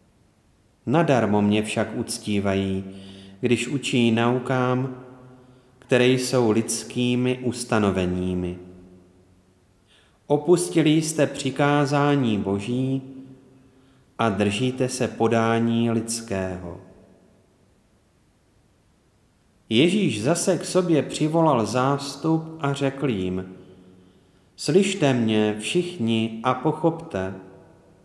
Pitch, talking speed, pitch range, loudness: 115 Hz, 75 wpm, 95-135 Hz, -23 LUFS